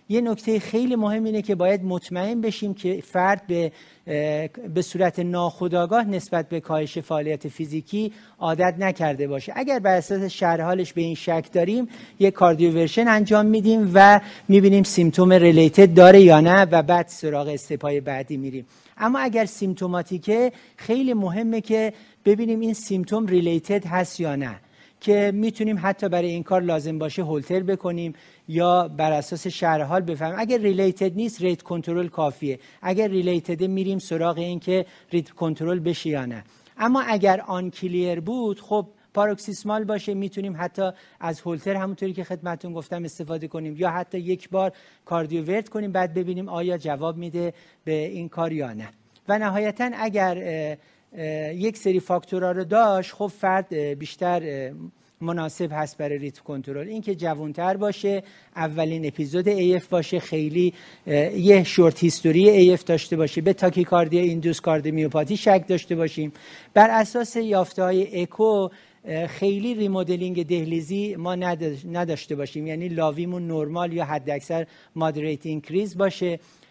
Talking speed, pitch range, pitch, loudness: 145 wpm, 165-195 Hz, 180 Hz, -22 LUFS